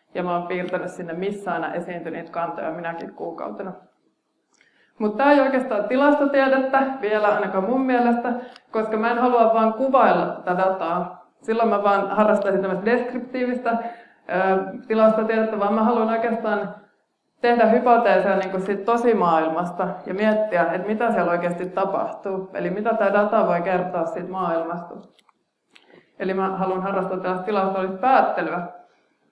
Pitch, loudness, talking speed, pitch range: 205 Hz, -21 LUFS, 140 wpm, 185-235 Hz